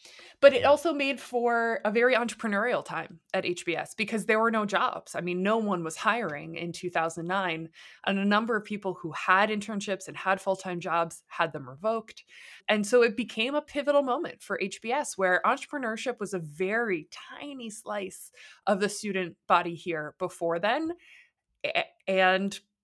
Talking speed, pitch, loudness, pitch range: 170 wpm, 205 Hz, -28 LUFS, 180-240 Hz